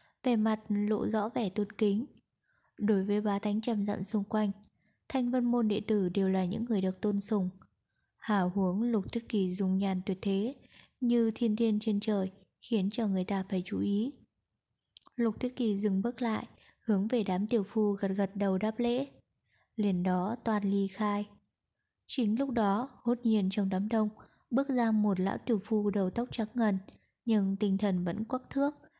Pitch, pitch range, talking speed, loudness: 210 Hz, 200-230 Hz, 190 wpm, -31 LUFS